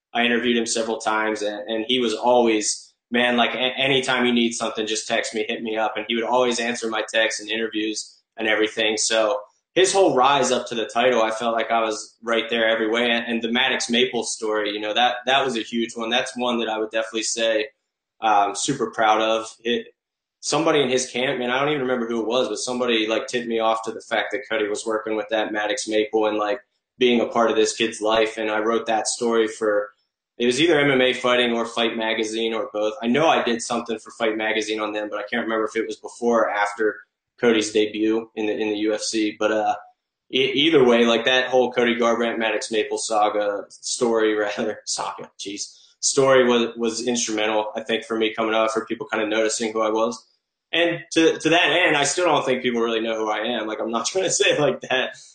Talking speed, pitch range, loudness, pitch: 235 wpm, 110-120 Hz, -21 LUFS, 115 Hz